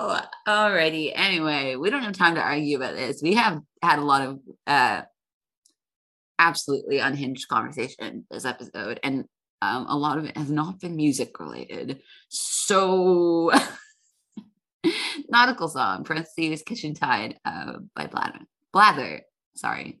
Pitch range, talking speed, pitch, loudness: 145-210 Hz, 130 wpm, 160 Hz, -24 LUFS